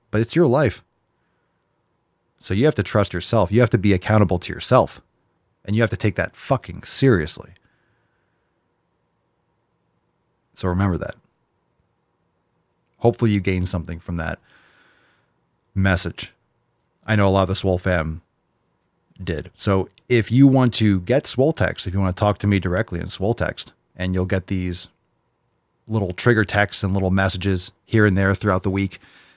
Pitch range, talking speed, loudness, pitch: 90-110 Hz, 160 wpm, -20 LUFS, 95 Hz